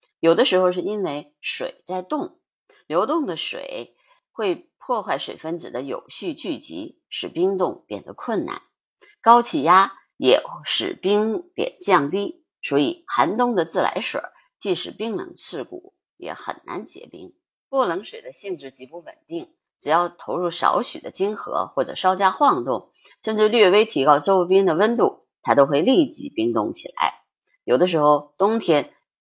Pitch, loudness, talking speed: 235 Hz, -21 LUFS, 230 characters per minute